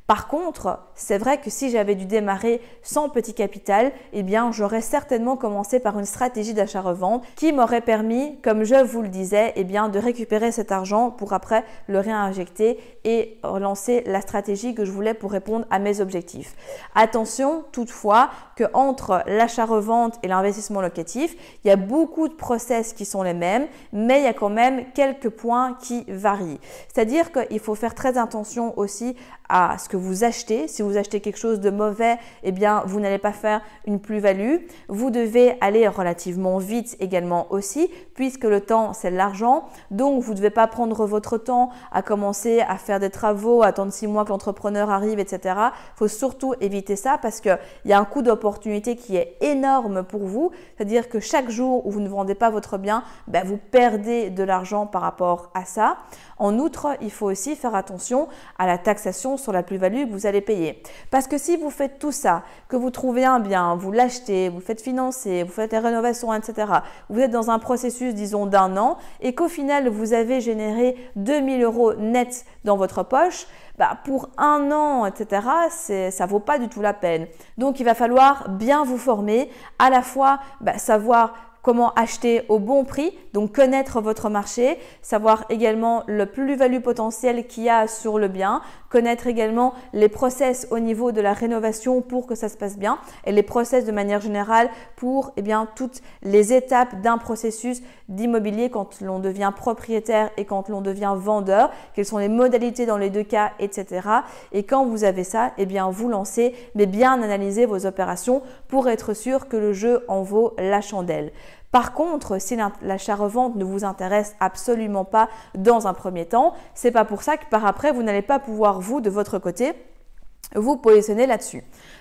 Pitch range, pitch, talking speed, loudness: 205-250 Hz, 225 Hz, 190 wpm, -22 LUFS